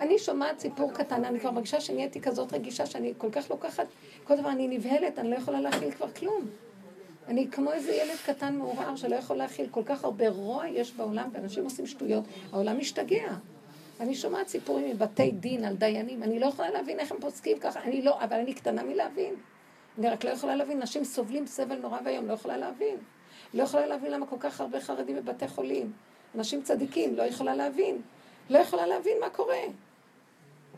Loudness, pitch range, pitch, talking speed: -31 LUFS, 220-290 Hz, 255 Hz, 160 wpm